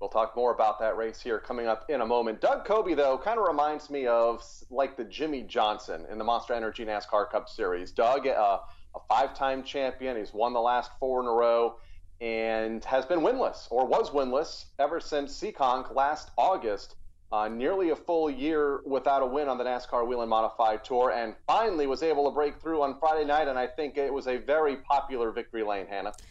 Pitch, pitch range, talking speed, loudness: 125 Hz, 110-140 Hz, 210 wpm, -28 LUFS